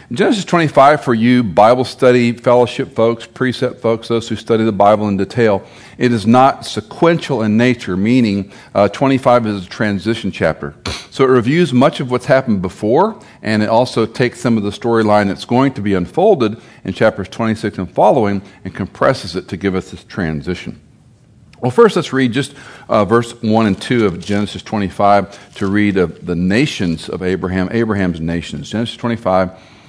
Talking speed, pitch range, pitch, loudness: 175 wpm, 100-125 Hz, 110 Hz, -15 LUFS